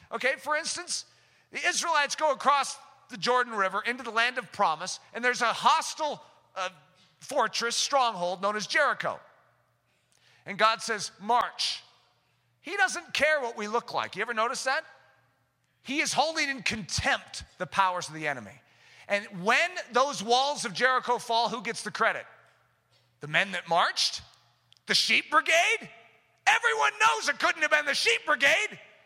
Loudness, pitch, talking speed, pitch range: -27 LUFS, 235 Hz, 160 wpm, 190-290 Hz